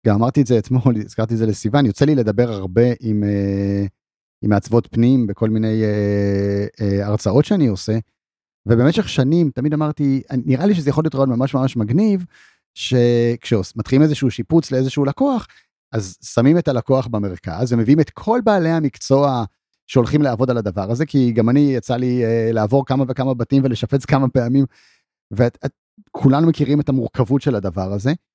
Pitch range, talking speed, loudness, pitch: 110-140 Hz, 155 wpm, -18 LUFS, 125 Hz